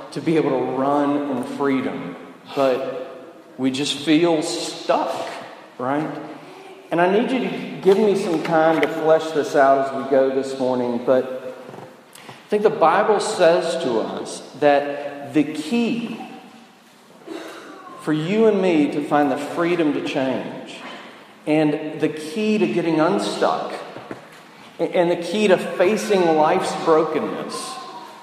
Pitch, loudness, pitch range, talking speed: 160 Hz, -20 LUFS, 145-195 Hz, 140 wpm